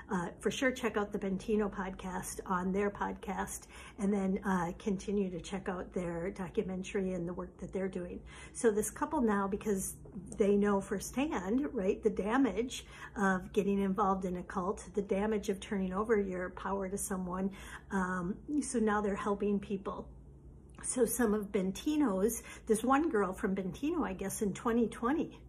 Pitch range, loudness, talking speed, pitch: 190-220 Hz, -34 LUFS, 165 wpm, 205 Hz